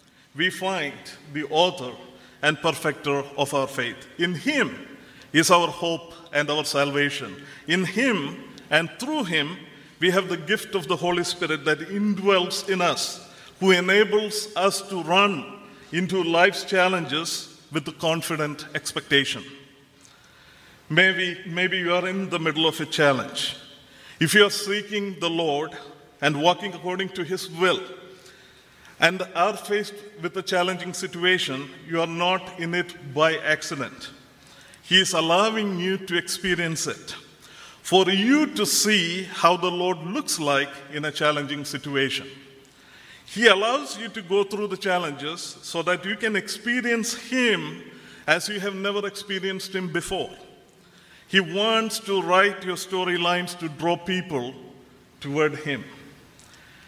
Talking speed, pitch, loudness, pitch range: 140 wpm, 175 Hz, -23 LUFS, 150-190 Hz